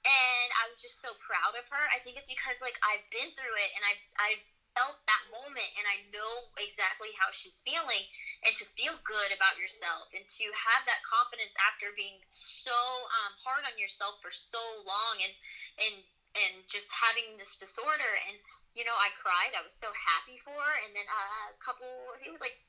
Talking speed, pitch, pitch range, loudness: 205 wpm, 220 Hz, 205-255 Hz, -31 LUFS